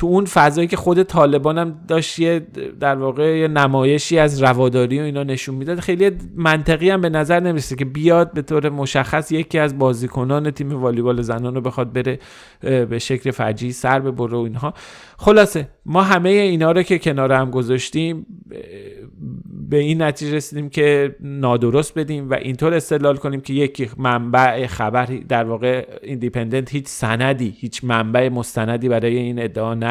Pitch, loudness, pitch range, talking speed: 140 Hz, -18 LUFS, 125-160 Hz, 165 wpm